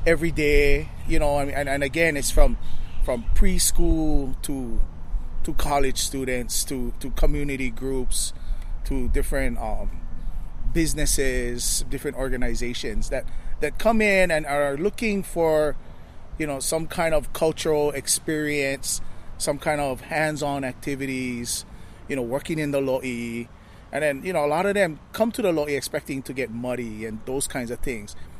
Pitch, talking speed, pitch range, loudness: 135 Hz, 150 wpm, 120-150 Hz, -25 LUFS